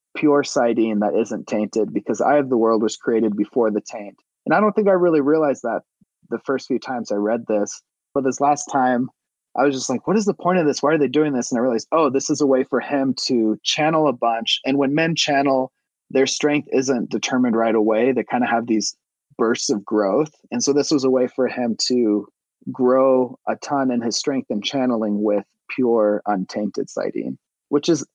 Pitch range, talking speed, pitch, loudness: 115-145 Hz, 220 wpm, 130 Hz, -20 LUFS